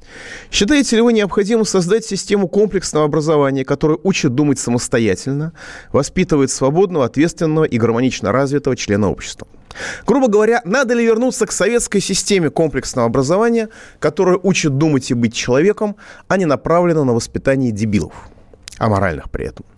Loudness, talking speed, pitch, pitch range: -16 LUFS, 135 wpm, 160 Hz, 135-205 Hz